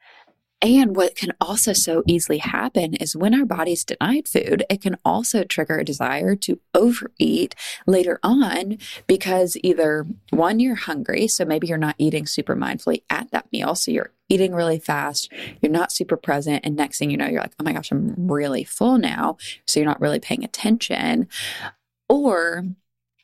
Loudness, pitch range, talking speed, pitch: -21 LUFS, 160-230 Hz, 175 wpm, 185 Hz